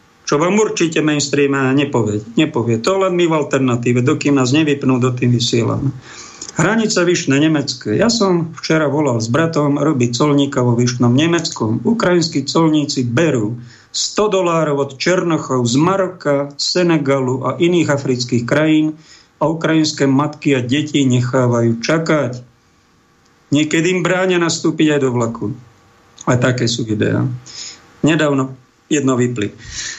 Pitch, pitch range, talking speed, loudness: 145 Hz, 125-160 Hz, 130 wpm, -16 LUFS